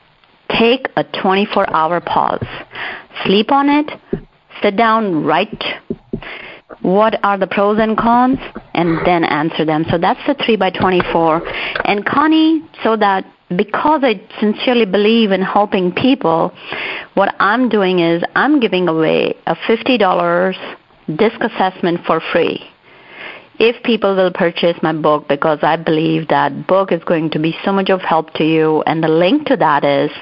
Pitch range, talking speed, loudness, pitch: 170-230 Hz, 155 wpm, -14 LUFS, 195 Hz